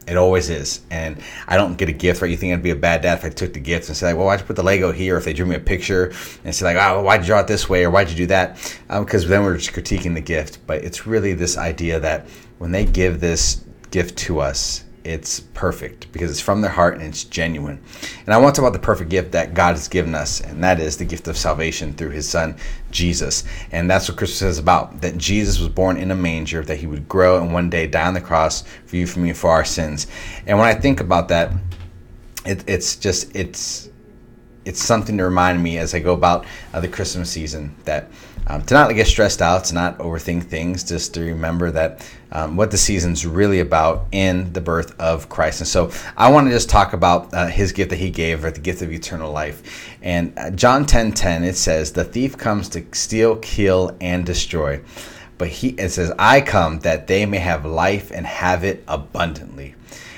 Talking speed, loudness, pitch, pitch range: 240 wpm, -19 LUFS, 90 Hz, 80-95 Hz